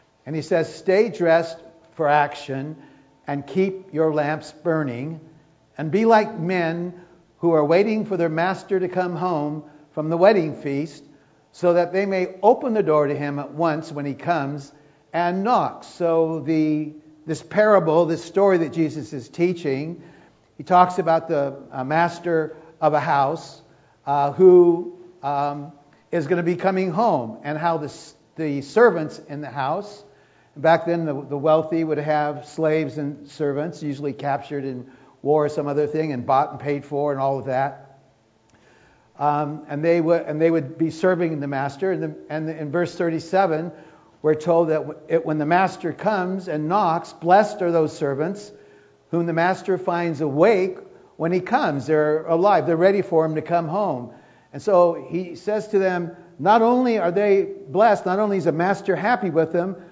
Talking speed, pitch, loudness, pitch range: 175 wpm, 160 Hz, -21 LUFS, 150-180 Hz